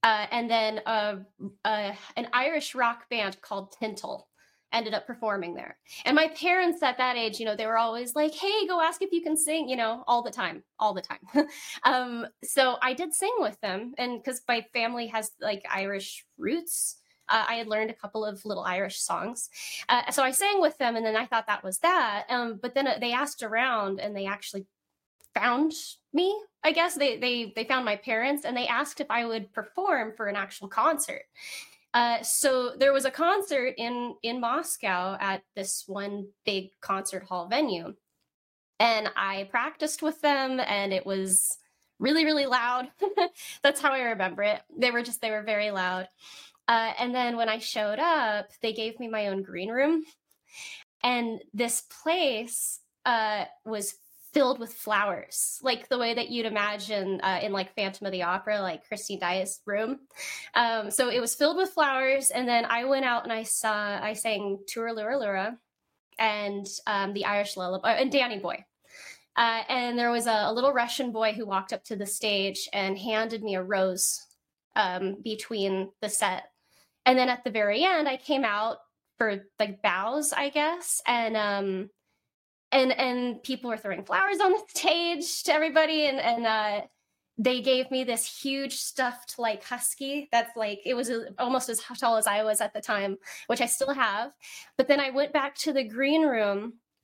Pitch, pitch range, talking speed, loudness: 235 Hz, 210-270 Hz, 190 wpm, -28 LUFS